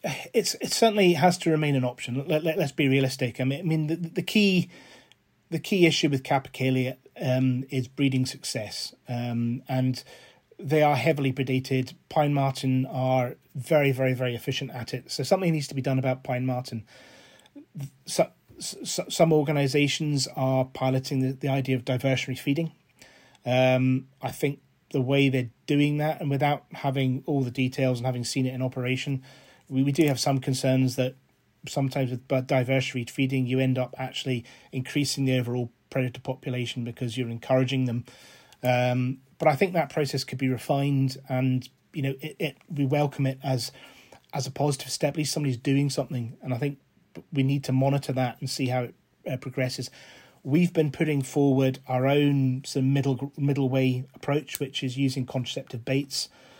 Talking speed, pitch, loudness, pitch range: 180 wpm, 135 Hz, -26 LUFS, 130-145 Hz